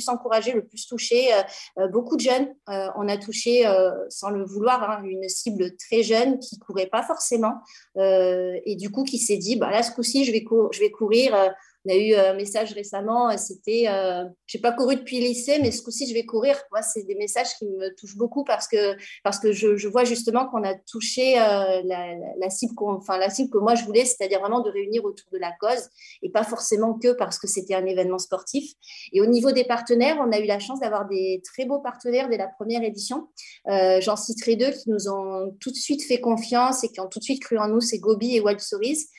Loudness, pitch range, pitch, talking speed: -23 LUFS, 200-245 Hz, 220 Hz, 245 wpm